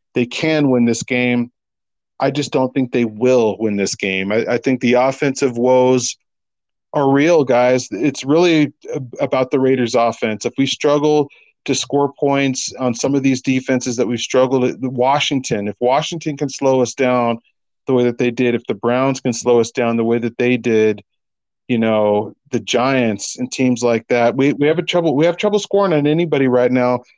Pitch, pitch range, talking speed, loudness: 125 Hz, 120-140 Hz, 195 wpm, -16 LUFS